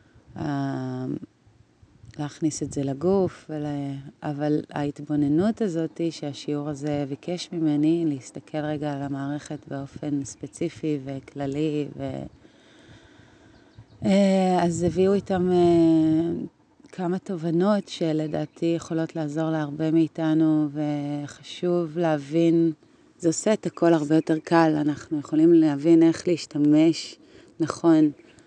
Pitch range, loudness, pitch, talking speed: 145-170 Hz, -24 LUFS, 155 Hz, 100 wpm